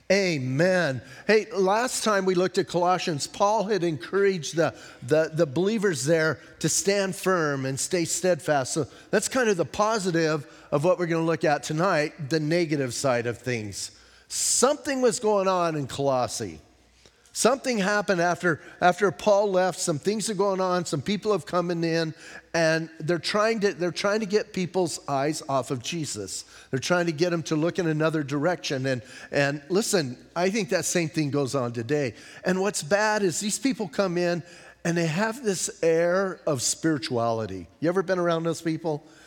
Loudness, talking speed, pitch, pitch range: -25 LUFS, 180 wpm, 170 Hz, 150-195 Hz